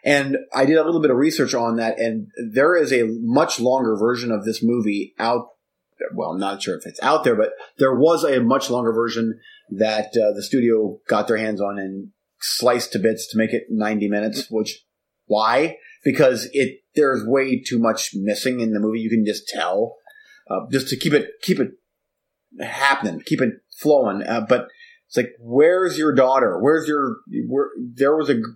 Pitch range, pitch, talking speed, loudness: 110-135 Hz, 115 Hz, 200 wpm, -20 LUFS